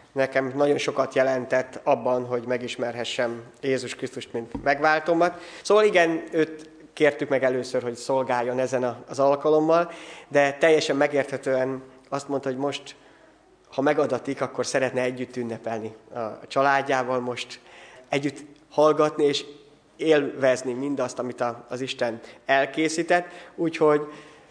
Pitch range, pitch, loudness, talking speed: 125-150 Hz, 135 Hz, -24 LUFS, 120 wpm